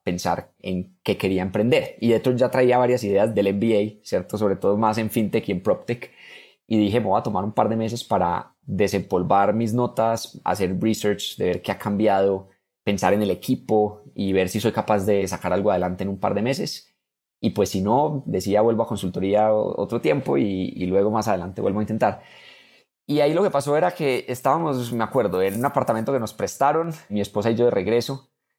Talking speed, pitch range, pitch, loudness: 215 wpm, 100-120 Hz, 110 Hz, -22 LUFS